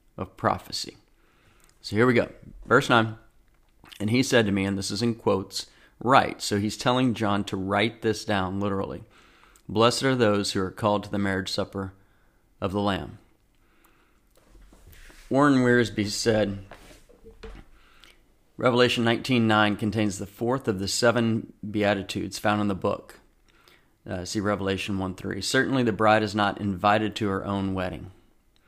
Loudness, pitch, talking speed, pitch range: -25 LUFS, 105 Hz, 155 wpm, 100-115 Hz